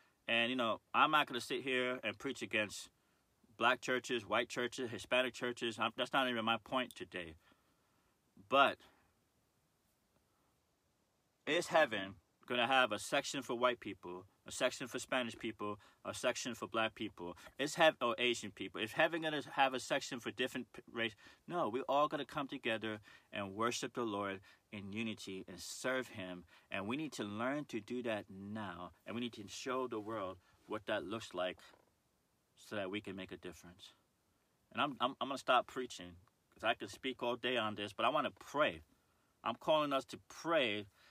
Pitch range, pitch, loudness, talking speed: 105-130 Hz, 115 Hz, -38 LUFS, 190 wpm